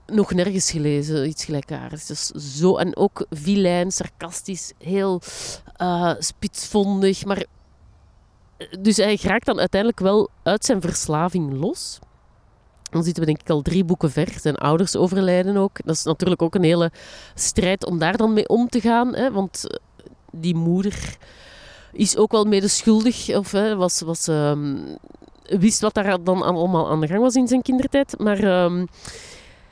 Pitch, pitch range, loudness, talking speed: 185 Hz, 165-210 Hz, -21 LUFS, 160 wpm